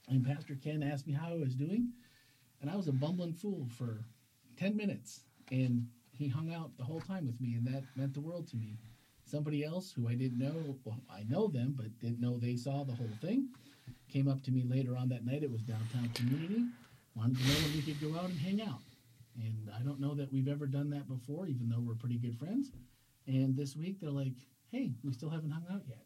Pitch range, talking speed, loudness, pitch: 120-150 Hz, 235 wpm, -38 LUFS, 135 Hz